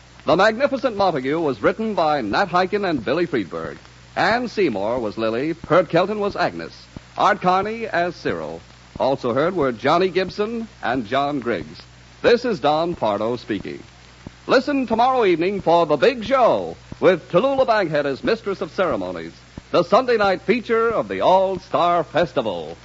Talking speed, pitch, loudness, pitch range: 155 wpm, 180 Hz, -20 LUFS, 140-210 Hz